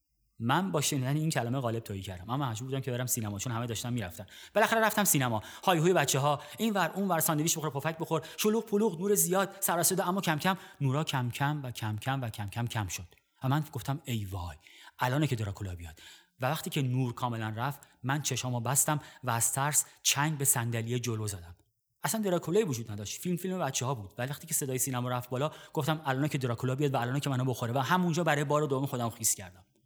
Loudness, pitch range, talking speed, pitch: -31 LUFS, 120-155 Hz, 225 wpm, 135 Hz